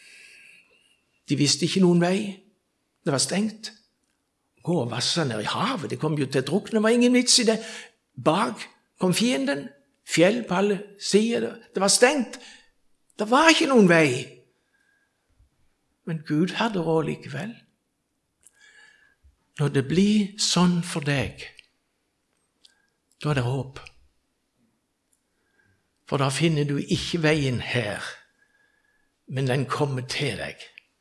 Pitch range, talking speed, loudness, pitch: 150-240 Hz, 130 wpm, -23 LUFS, 190 Hz